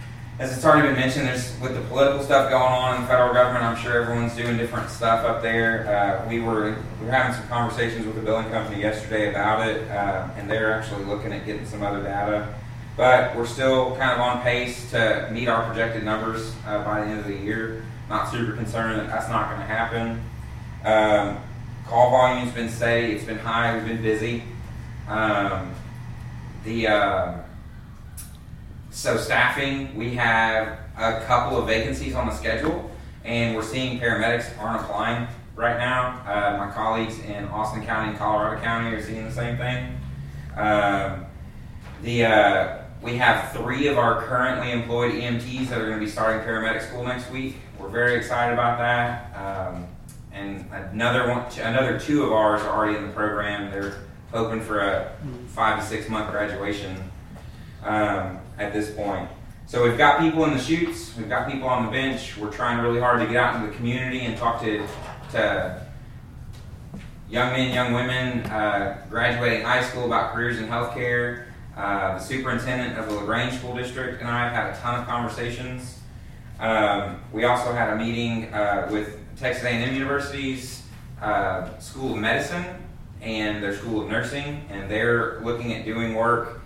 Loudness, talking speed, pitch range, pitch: -24 LUFS, 180 wpm, 105-120 Hz, 115 Hz